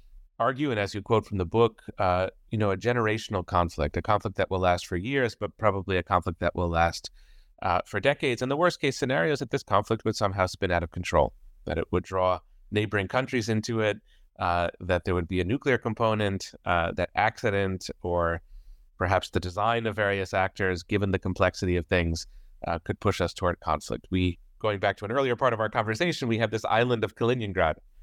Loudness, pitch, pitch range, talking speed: -27 LUFS, 100 Hz, 90-110 Hz, 210 wpm